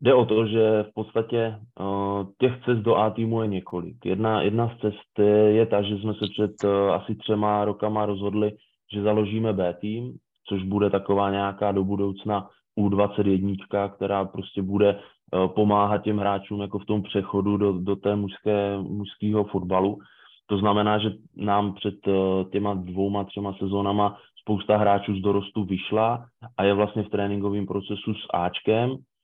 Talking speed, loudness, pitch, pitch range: 160 wpm, -25 LUFS, 100 Hz, 100-105 Hz